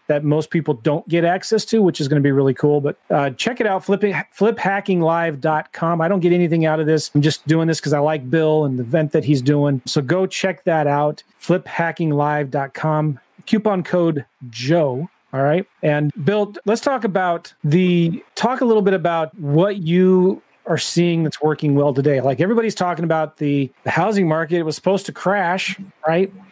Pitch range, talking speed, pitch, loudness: 150-185 Hz, 190 wpm, 165 Hz, -18 LUFS